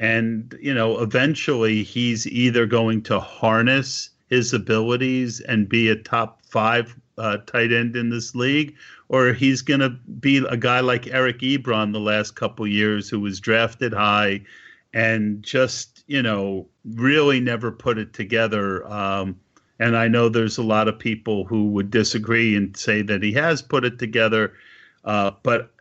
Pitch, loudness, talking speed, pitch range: 115 Hz, -21 LUFS, 165 wpm, 105-125 Hz